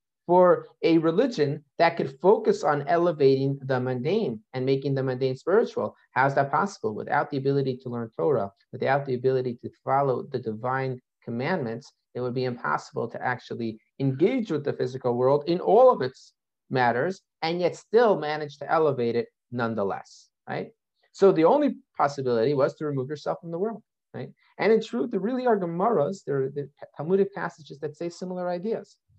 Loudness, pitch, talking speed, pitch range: -25 LUFS, 145 Hz, 175 wpm, 130-180 Hz